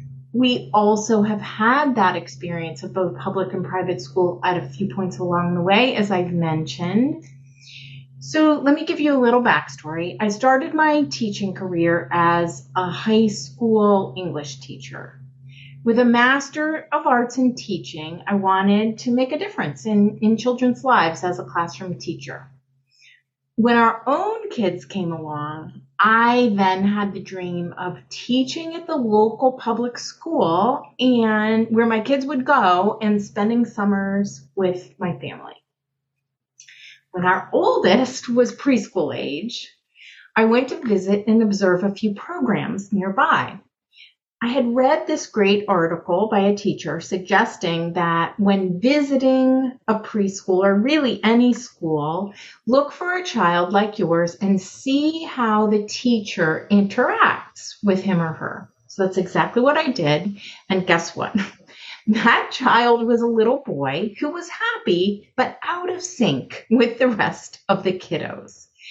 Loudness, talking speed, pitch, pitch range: -20 LUFS, 150 wpm, 205 Hz, 175-245 Hz